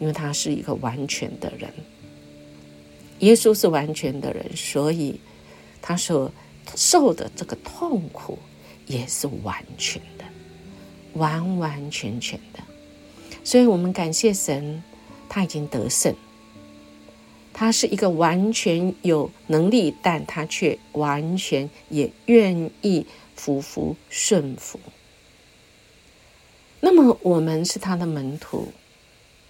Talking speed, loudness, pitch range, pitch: 160 characters per minute, -22 LUFS, 110-185 Hz, 155 Hz